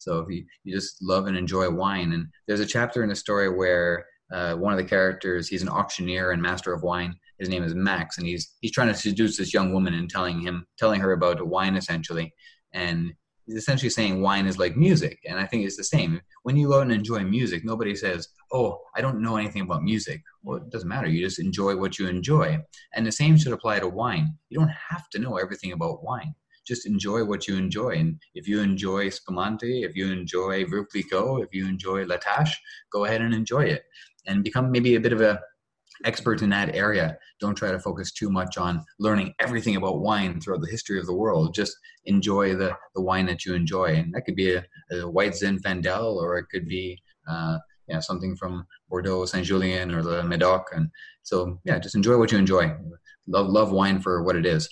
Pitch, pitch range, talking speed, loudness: 95 Hz, 90-110 Hz, 220 wpm, -25 LUFS